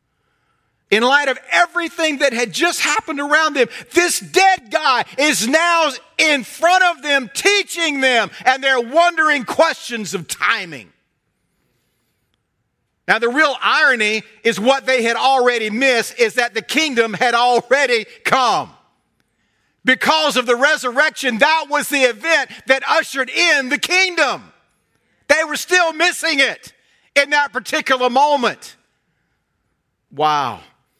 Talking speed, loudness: 130 wpm, -15 LUFS